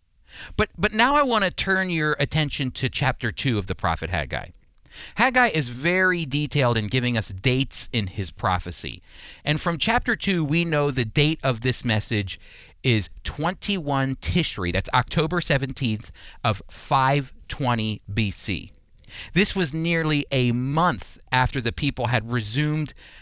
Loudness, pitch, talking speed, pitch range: -23 LUFS, 130 Hz, 145 wpm, 110-155 Hz